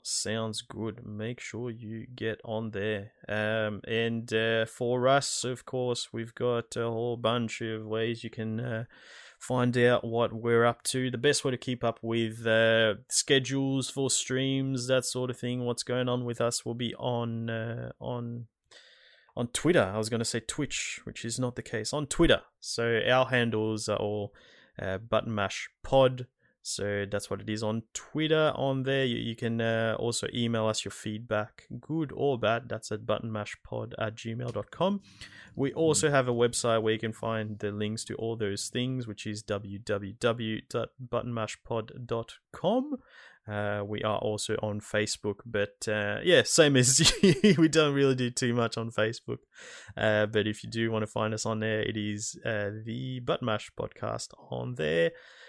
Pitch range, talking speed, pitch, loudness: 110-125 Hz, 175 wpm, 115 Hz, -29 LUFS